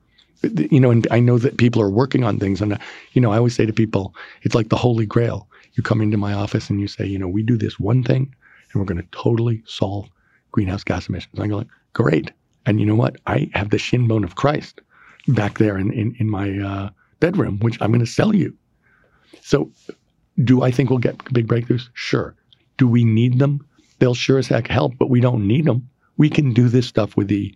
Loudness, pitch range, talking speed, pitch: -19 LUFS, 105-130 Hz, 235 wpm, 115 Hz